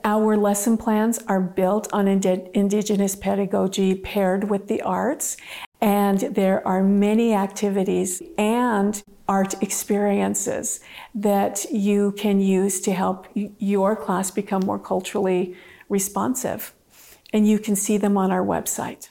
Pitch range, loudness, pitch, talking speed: 195-210 Hz, -22 LUFS, 200 Hz, 130 wpm